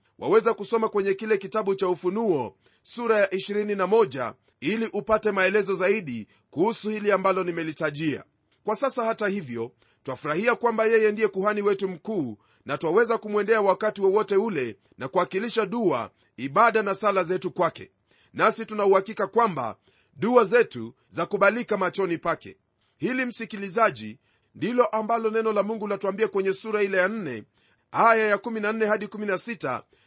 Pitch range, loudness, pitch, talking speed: 185-220 Hz, -25 LUFS, 205 Hz, 130 wpm